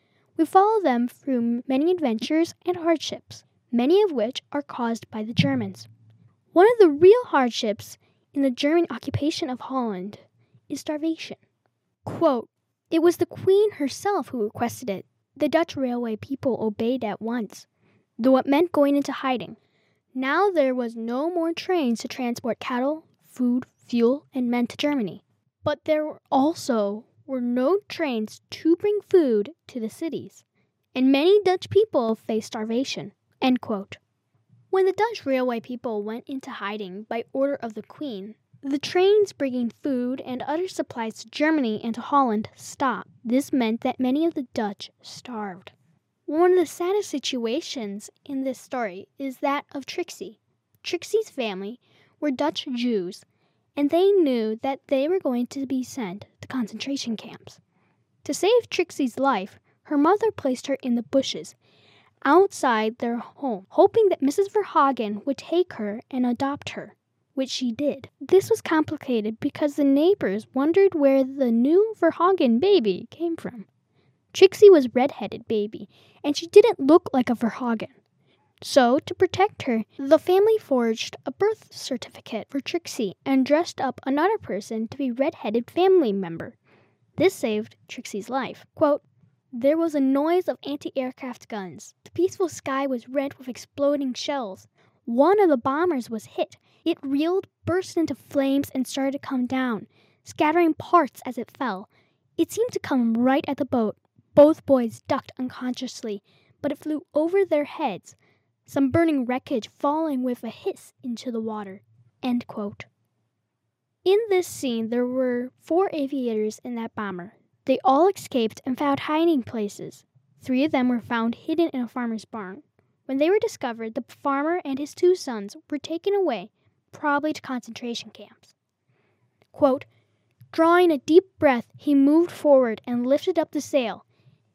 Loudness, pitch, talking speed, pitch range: -24 LUFS, 270 Hz, 155 wpm, 235-320 Hz